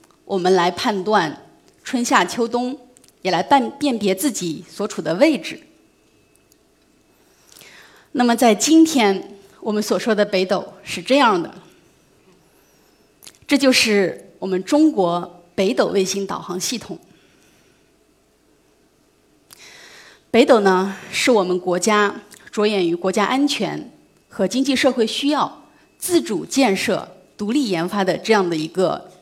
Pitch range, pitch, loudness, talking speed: 190-255 Hz, 205 Hz, -19 LUFS, 180 characters per minute